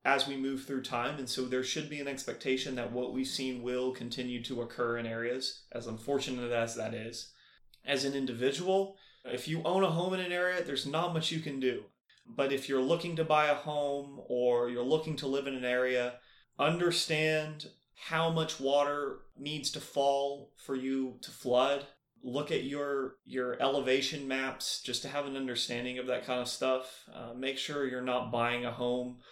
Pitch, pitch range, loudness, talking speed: 135 Hz, 125-145 Hz, -33 LUFS, 195 wpm